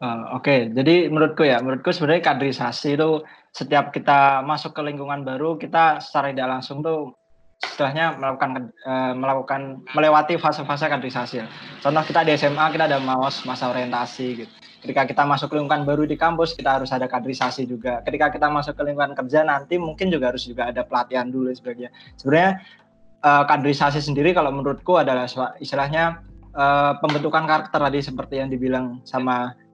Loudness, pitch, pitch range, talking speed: -21 LUFS, 140 Hz, 130-150 Hz, 165 wpm